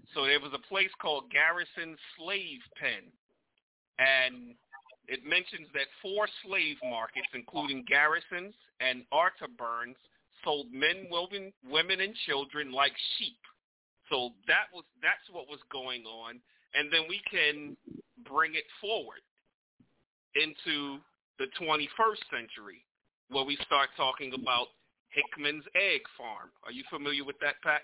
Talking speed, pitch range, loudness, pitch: 130 wpm, 130-175 Hz, -31 LUFS, 145 Hz